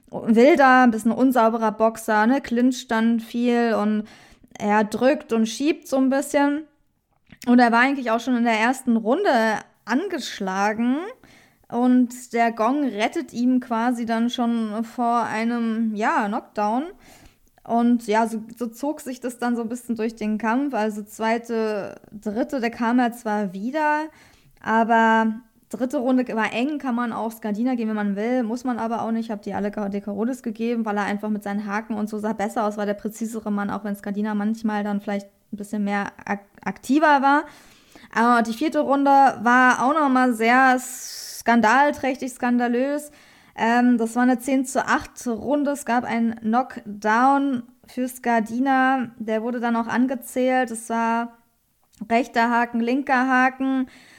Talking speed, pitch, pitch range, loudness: 165 wpm, 235 Hz, 220-255 Hz, -22 LUFS